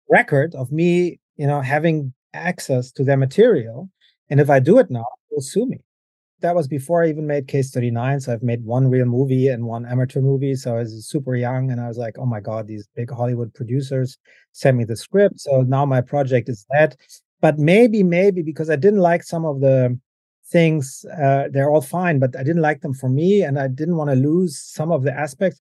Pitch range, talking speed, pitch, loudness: 125-160 Hz, 220 wpm, 140 Hz, -19 LUFS